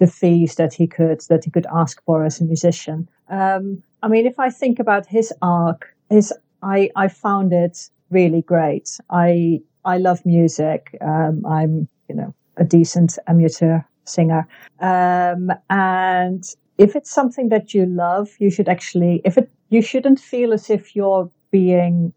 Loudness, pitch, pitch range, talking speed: -17 LUFS, 180 Hz, 165-195 Hz, 165 wpm